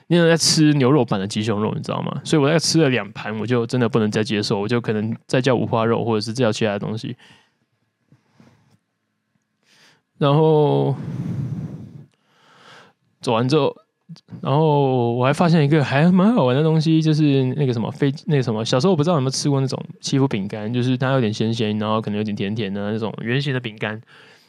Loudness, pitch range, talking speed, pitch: -19 LUFS, 115-155 Hz, 300 characters per minute, 135 Hz